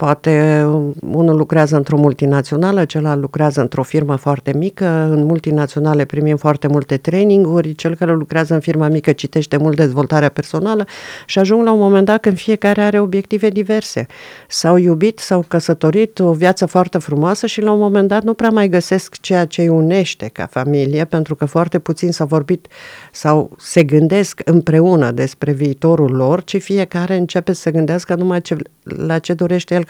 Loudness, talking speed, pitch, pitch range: -14 LUFS, 175 wpm, 165 Hz, 150-185 Hz